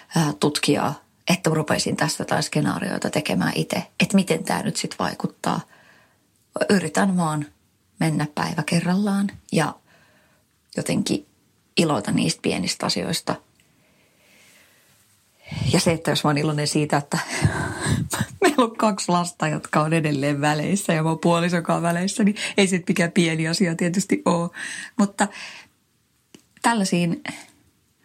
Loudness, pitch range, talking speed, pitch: -22 LUFS, 150-195 Hz, 120 wpm, 170 Hz